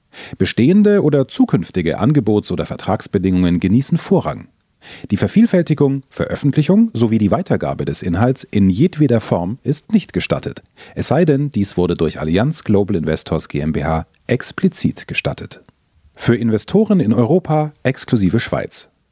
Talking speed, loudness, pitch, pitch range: 125 wpm, -16 LUFS, 120 Hz, 90-155 Hz